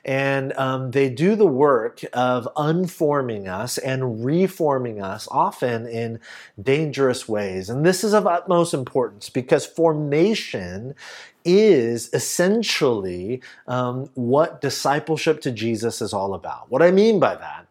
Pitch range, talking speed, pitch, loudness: 125-170 Hz, 130 wpm, 135 Hz, -21 LUFS